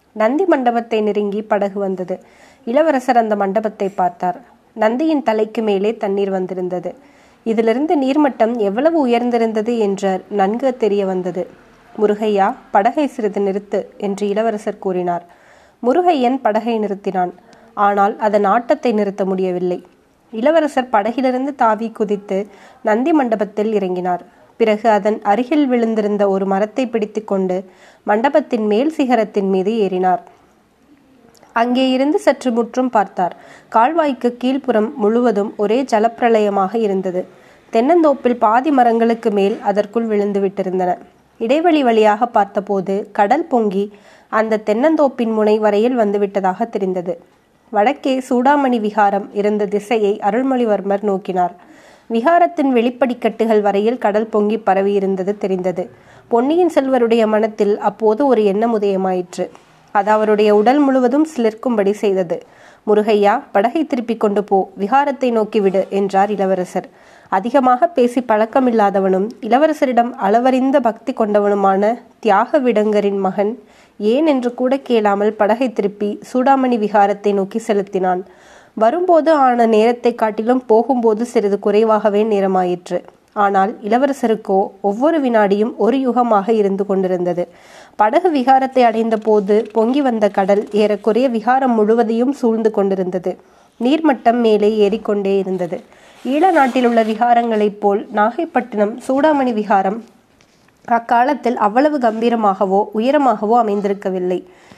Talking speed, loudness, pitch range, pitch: 105 wpm, -16 LUFS, 200-245 Hz, 220 Hz